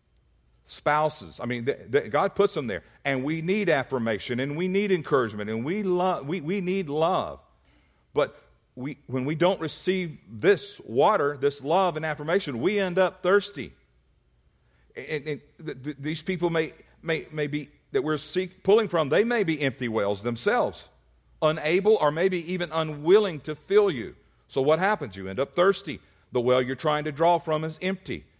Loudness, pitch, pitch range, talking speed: -26 LUFS, 155 Hz, 125-185 Hz, 180 wpm